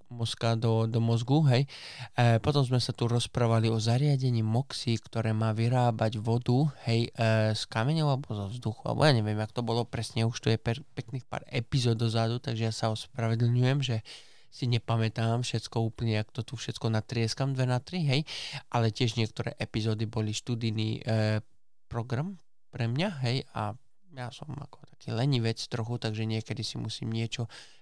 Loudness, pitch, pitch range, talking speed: -30 LUFS, 115 Hz, 110-130 Hz, 175 wpm